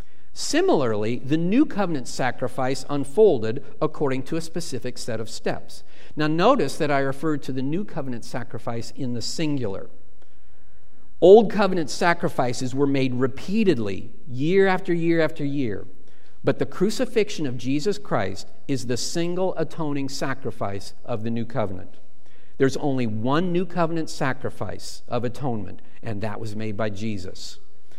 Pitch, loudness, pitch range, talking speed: 135 Hz, -24 LUFS, 115-165 Hz, 140 wpm